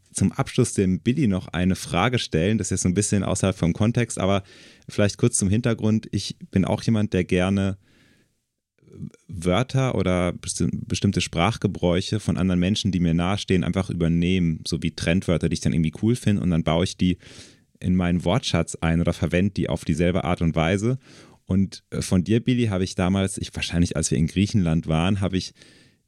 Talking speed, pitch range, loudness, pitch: 190 wpm, 85-105 Hz, -23 LUFS, 95 Hz